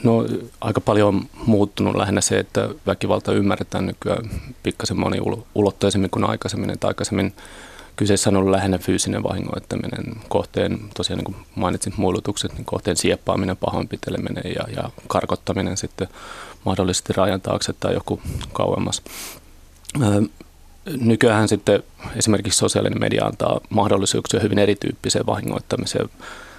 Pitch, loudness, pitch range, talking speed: 100 Hz, -21 LUFS, 95-110 Hz, 120 wpm